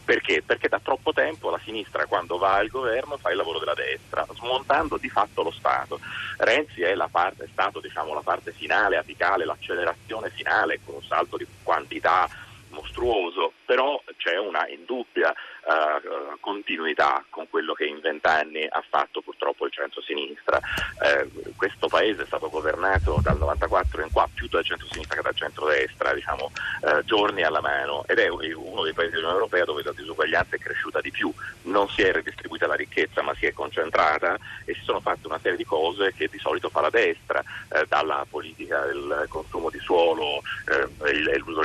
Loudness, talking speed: -25 LUFS, 180 wpm